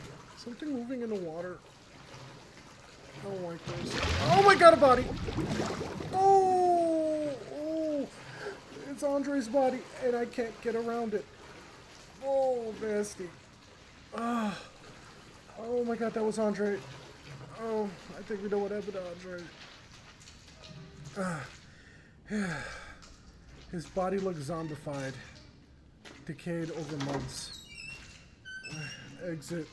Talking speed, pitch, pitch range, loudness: 105 wpm, 210 Hz, 165-255 Hz, -31 LUFS